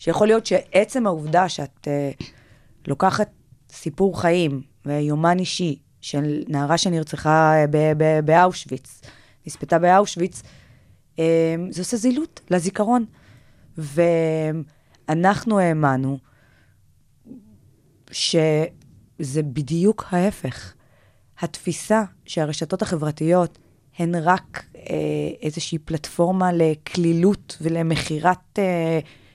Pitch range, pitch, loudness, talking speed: 140-180 Hz, 160 Hz, -21 LUFS, 80 wpm